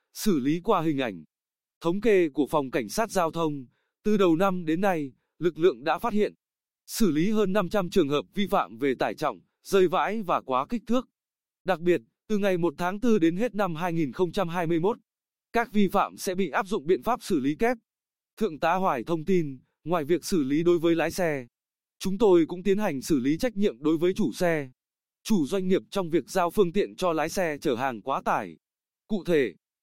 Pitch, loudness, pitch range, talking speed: 185 Hz, -26 LUFS, 170-215 Hz, 215 wpm